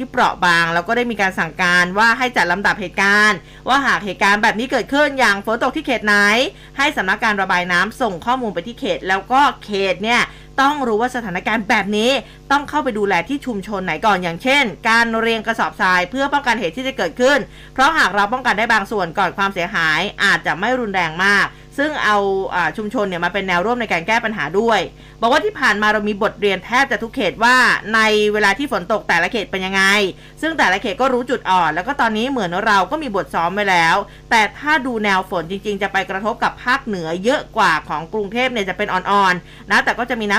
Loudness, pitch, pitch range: -17 LUFS, 215 Hz, 190-245 Hz